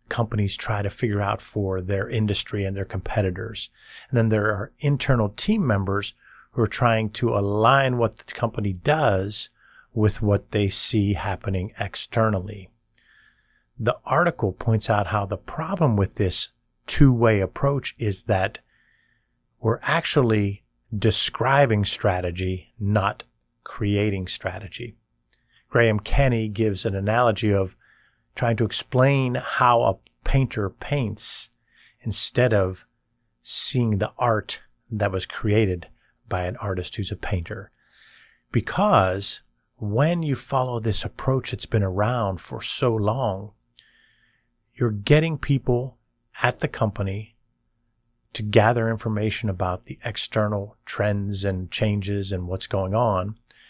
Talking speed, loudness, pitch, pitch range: 125 wpm, -23 LUFS, 110 Hz, 100-120 Hz